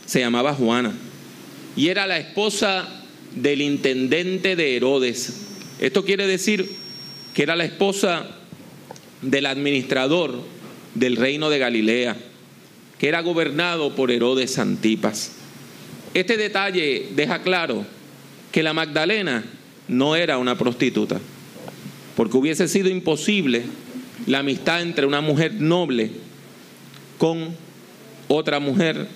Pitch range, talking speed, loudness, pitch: 130-185 Hz, 110 wpm, -21 LUFS, 155 Hz